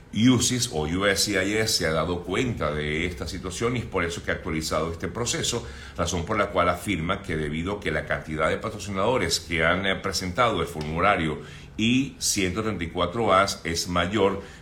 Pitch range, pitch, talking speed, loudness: 80-105 Hz, 90 Hz, 165 wpm, -25 LUFS